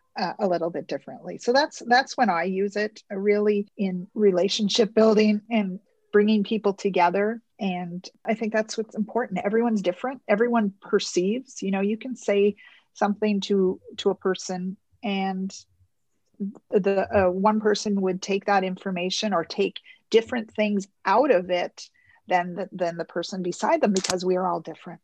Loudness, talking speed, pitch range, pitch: -24 LUFS, 165 wpm, 185-220 Hz, 200 Hz